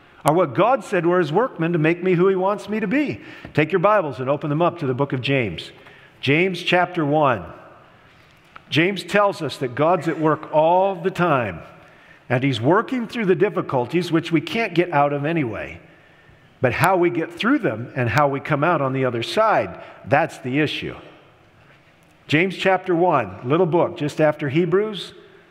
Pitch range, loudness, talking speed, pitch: 145-185 Hz, -20 LUFS, 190 wpm, 170 Hz